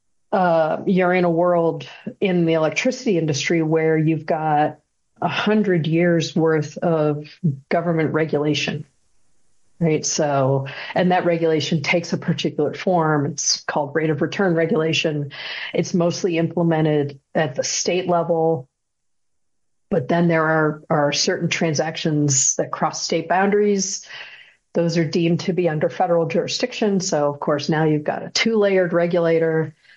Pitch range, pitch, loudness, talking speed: 155-175 Hz, 165 Hz, -20 LUFS, 140 wpm